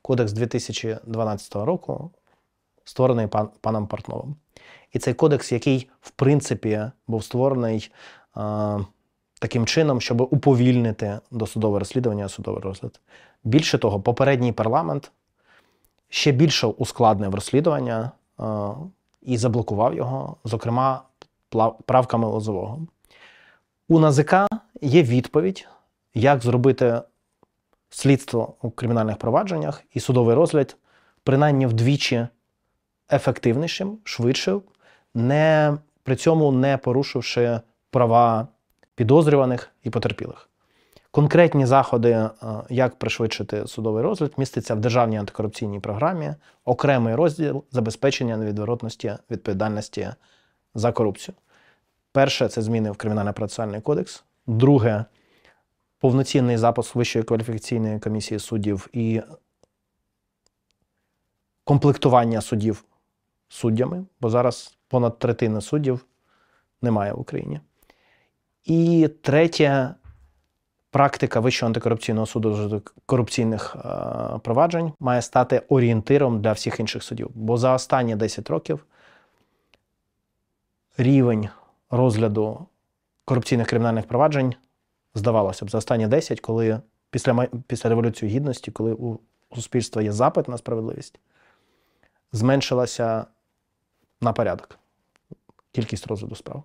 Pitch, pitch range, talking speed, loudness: 120 Hz, 110-135 Hz, 95 wpm, -22 LUFS